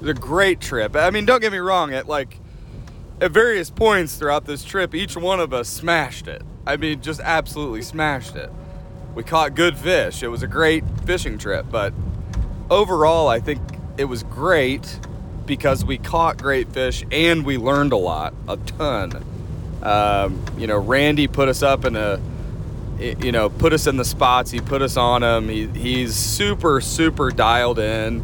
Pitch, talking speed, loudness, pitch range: 135 Hz, 185 wpm, -20 LUFS, 115-155 Hz